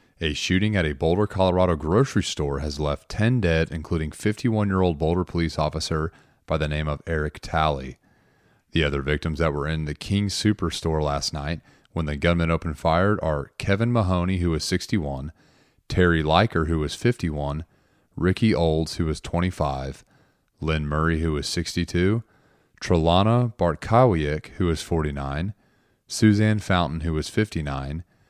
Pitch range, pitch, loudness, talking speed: 75-95 Hz, 85 Hz, -24 LUFS, 150 wpm